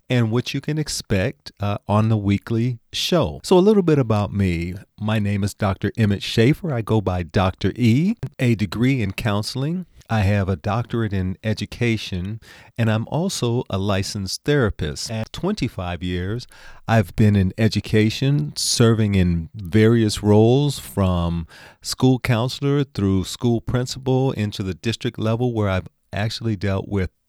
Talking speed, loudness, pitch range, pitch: 150 wpm, -21 LUFS, 100-125 Hz, 110 Hz